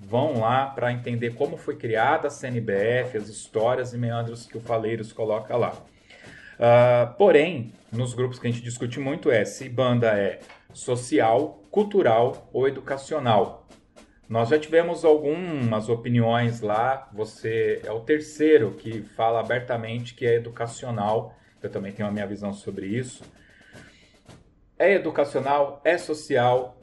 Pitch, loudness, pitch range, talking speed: 120 Hz, -24 LUFS, 115-135 Hz, 140 wpm